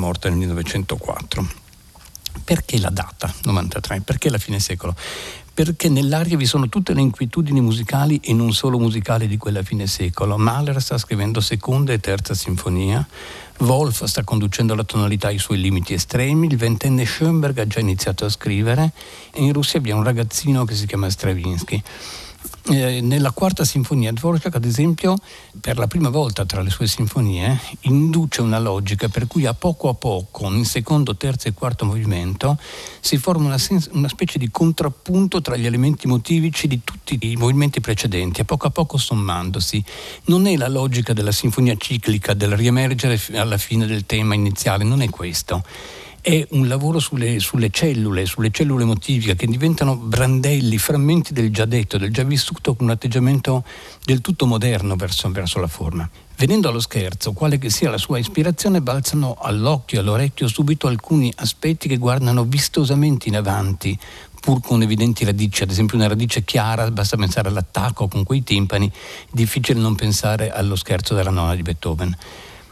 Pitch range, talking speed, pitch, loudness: 105-140 Hz, 170 wpm, 120 Hz, -19 LUFS